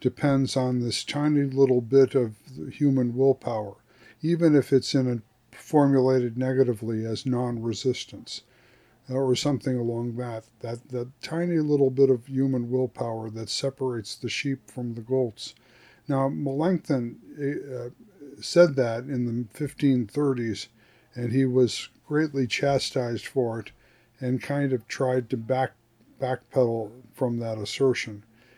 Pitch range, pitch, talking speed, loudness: 120-135 Hz, 130 Hz, 130 wpm, -26 LUFS